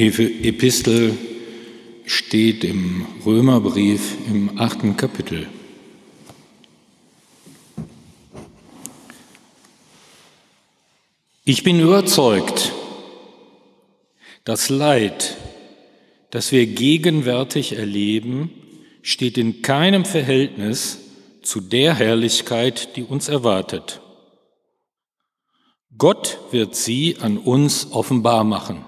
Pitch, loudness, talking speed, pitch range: 115 Hz, -18 LUFS, 70 wpm, 110-135 Hz